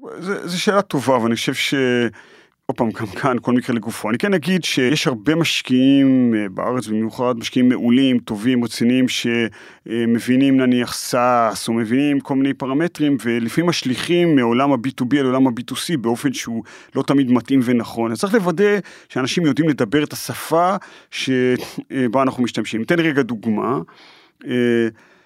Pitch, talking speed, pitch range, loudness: 130 Hz, 145 wpm, 120-145 Hz, -18 LUFS